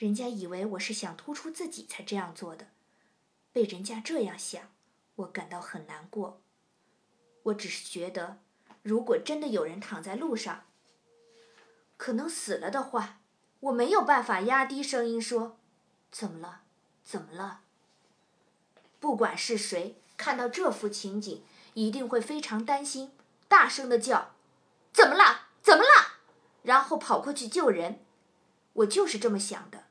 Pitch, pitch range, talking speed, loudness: 230 Hz, 200-270 Hz, 215 characters per minute, -27 LUFS